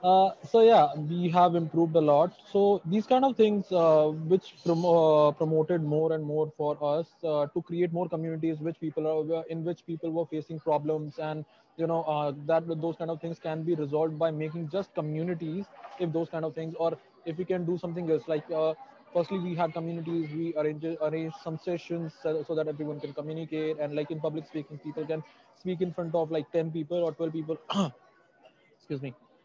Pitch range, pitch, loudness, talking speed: 155-175 Hz, 165 Hz, -29 LUFS, 205 wpm